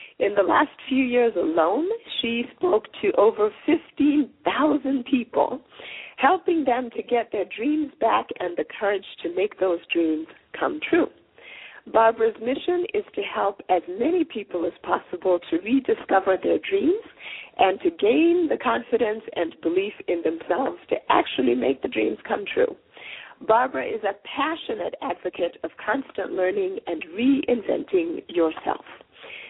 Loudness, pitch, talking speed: -24 LUFS, 255 Hz, 140 wpm